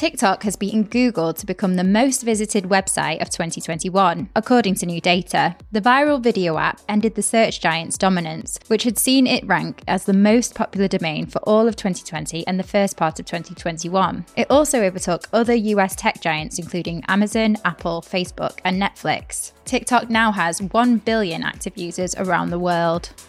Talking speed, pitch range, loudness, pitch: 175 wpm, 175-225 Hz, -20 LUFS, 195 Hz